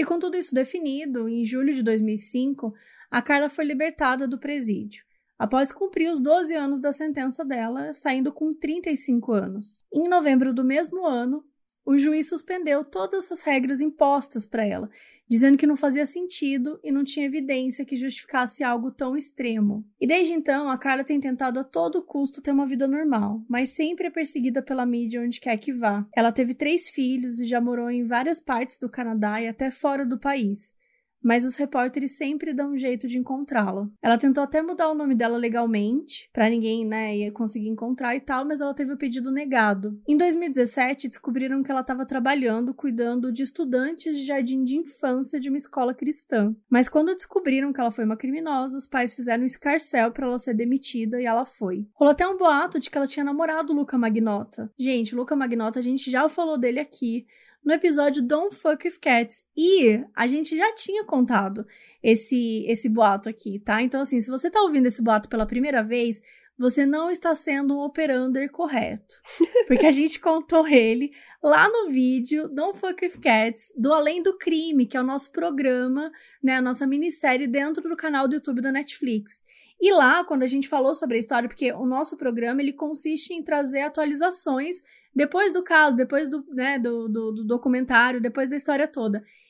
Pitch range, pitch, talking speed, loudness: 240-300 Hz, 270 Hz, 190 wpm, -24 LUFS